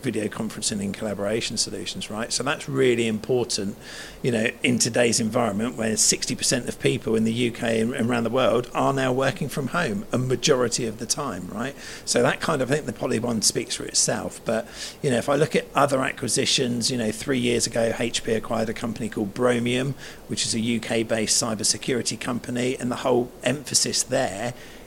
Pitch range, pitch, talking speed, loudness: 115-125 Hz, 120 Hz, 195 wpm, -24 LUFS